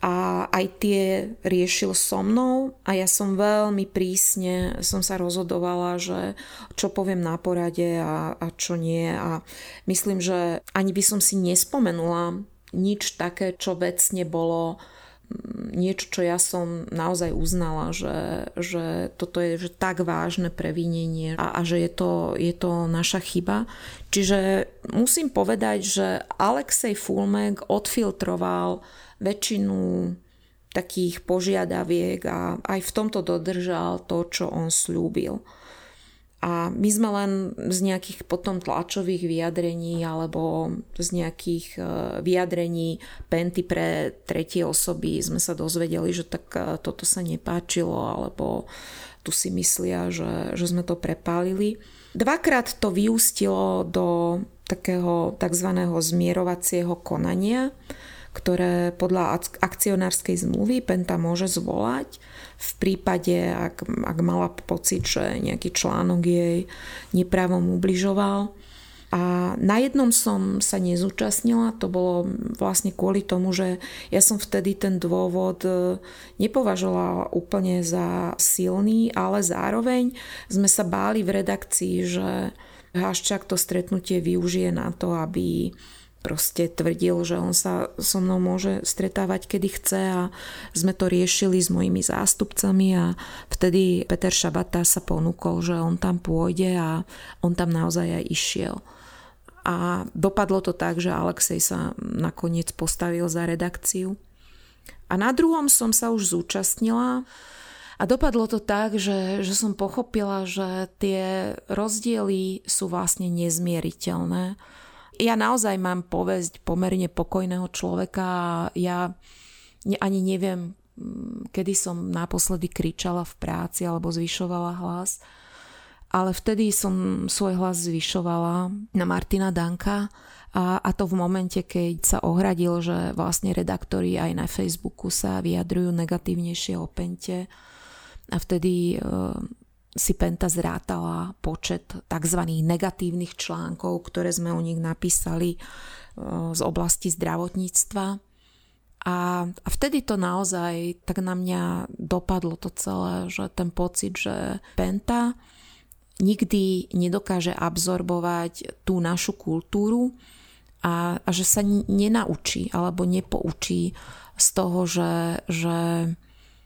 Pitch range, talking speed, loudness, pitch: 170-195 Hz, 120 wpm, -24 LUFS, 180 Hz